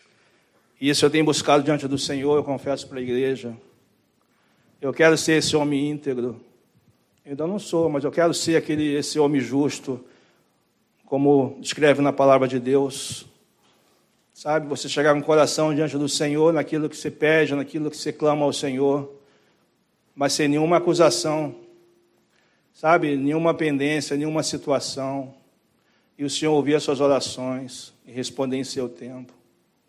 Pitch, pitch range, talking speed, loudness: 145 Hz, 135-155 Hz, 155 wpm, -22 LUFS